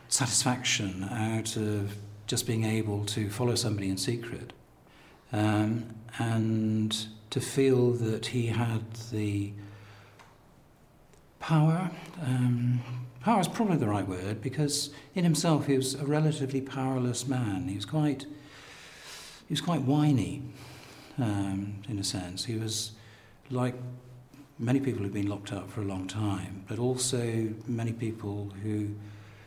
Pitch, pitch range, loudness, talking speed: 115 Hz, 105-135 Hz, -30 LUFS, 135 wpm